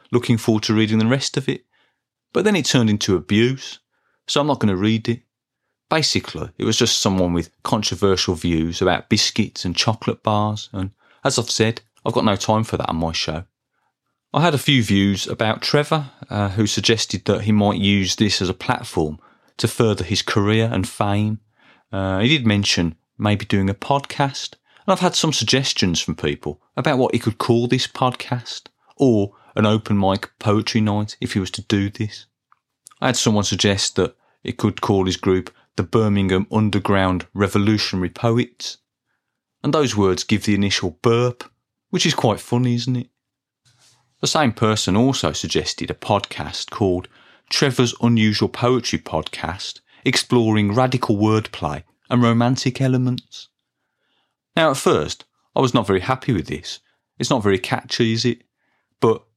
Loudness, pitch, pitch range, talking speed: -20 LUFS, 110 Hz, 100-125 Hz, 170 wpm